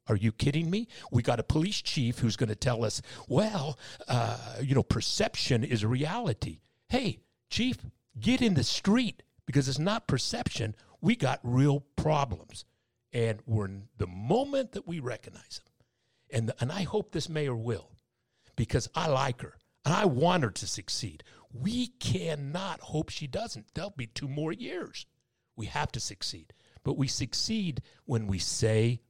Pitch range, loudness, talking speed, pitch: 115-155 Hz, -31 LUFS, 170 wpm, 125 Hz